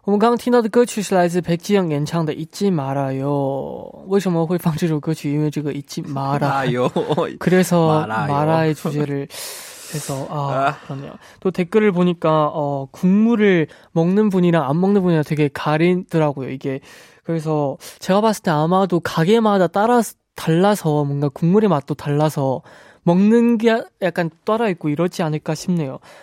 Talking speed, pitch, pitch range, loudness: 315 characters per minute, 165 Hz, 150-190 Hz, -19 LUFS